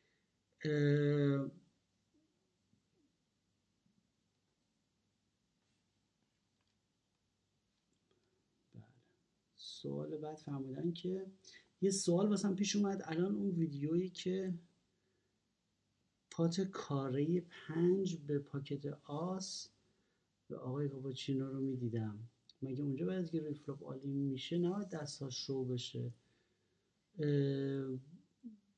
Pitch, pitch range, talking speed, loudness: 145 Hz, 135-180 Hz, 75 wpm, -39 LUFS